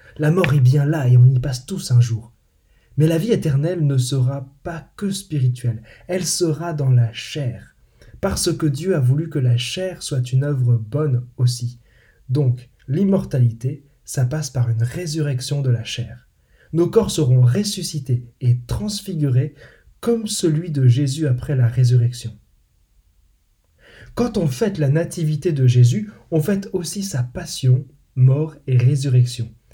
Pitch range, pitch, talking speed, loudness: 120-160 Hz, 135 Hz, 155 wpm, -19 LUFS